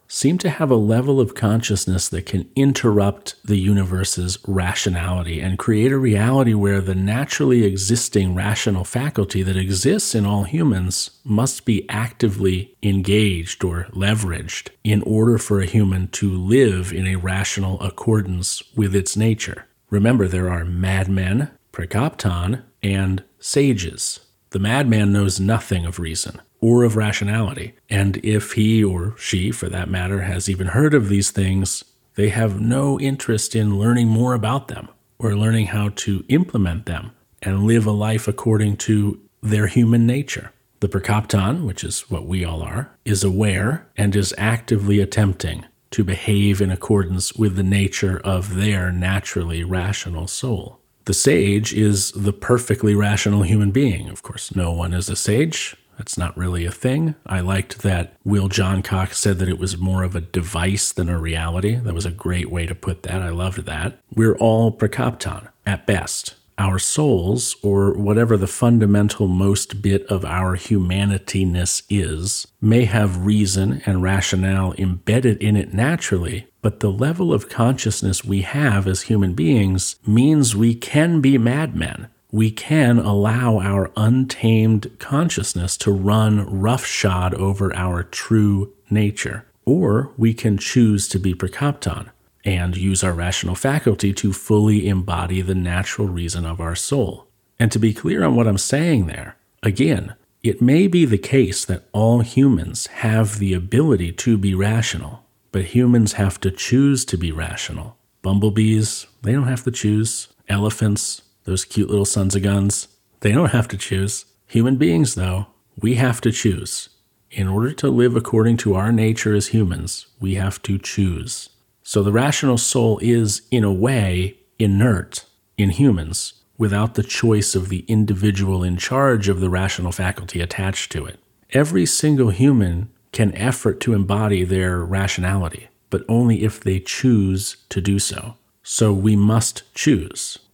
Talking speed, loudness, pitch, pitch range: 155 wpm, -19 LUFS, 105 Hz, 95-115 Hz